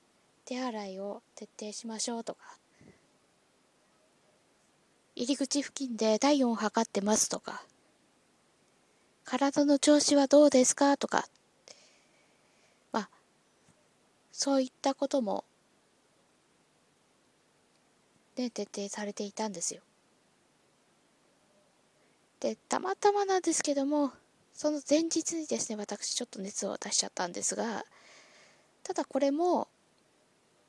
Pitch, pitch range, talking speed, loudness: 270 Hz, 220-290 Hz, 205 characters per minute, -30 LUFS